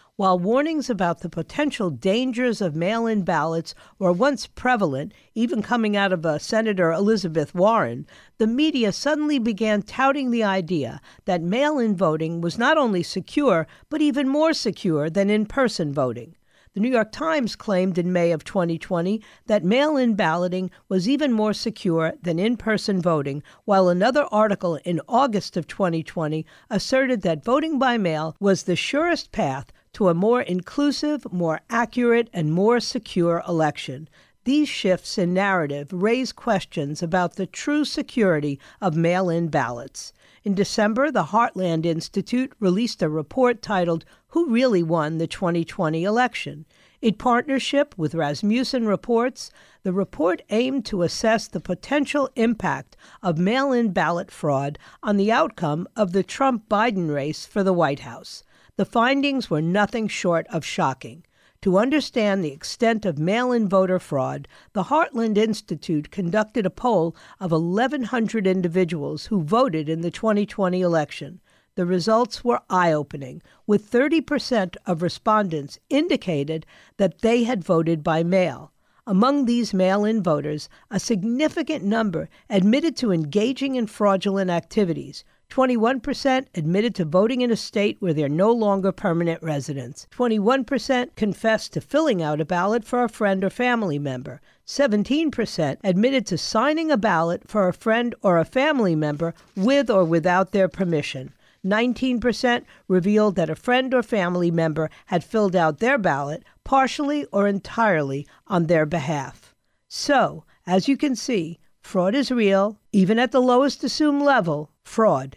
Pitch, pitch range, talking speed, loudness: 200 Hz, 170-240 Hz, 150 wpm, -22 LUFS